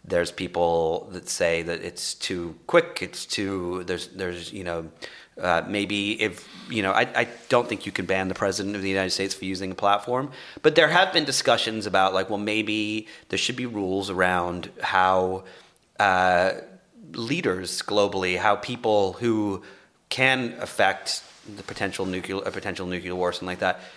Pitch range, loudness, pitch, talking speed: 90-105 Hz, -25 LUFS, 95 Hz, 175 wpm